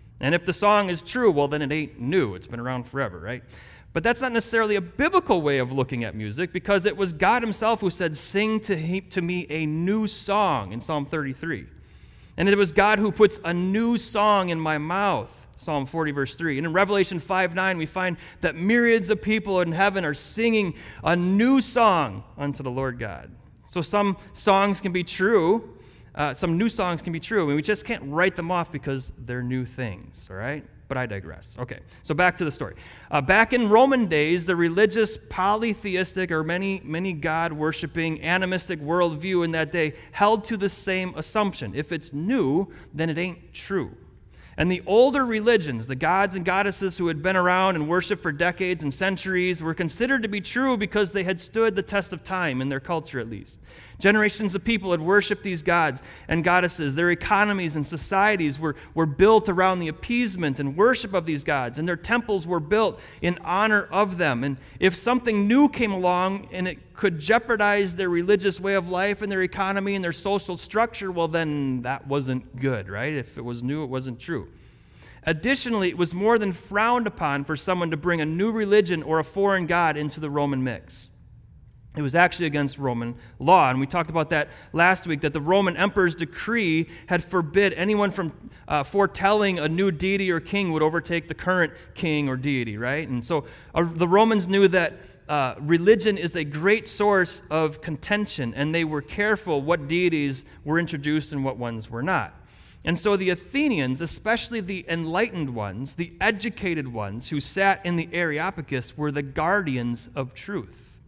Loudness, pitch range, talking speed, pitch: -23 LUFS, 150-200 Hz, 195 wpm, 175 Hz